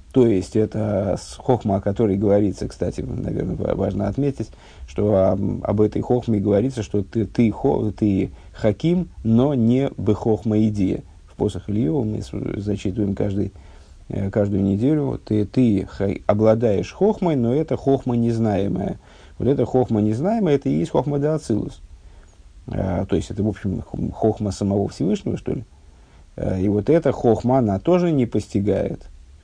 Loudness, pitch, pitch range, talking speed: -21 LUFS, 105 Hz, 95-120 Hz, 145 wpm